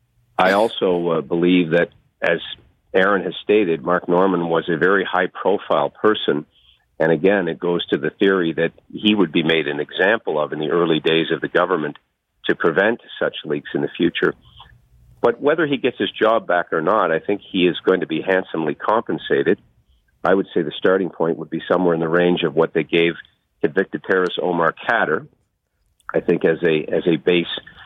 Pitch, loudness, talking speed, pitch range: 85 Hz, -19 LUFS, 195 wpm, 80-95 Hz